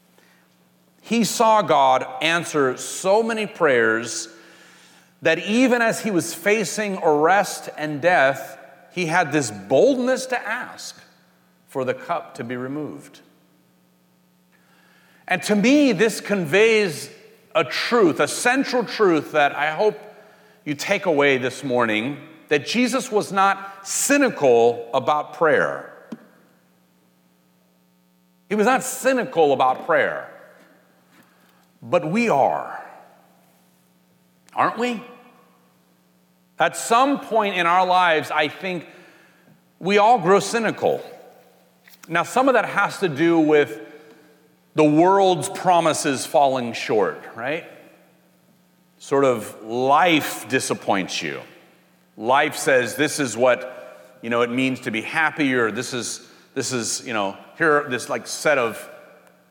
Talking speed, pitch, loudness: 120 wpm, 155 Hz, -20 LUFS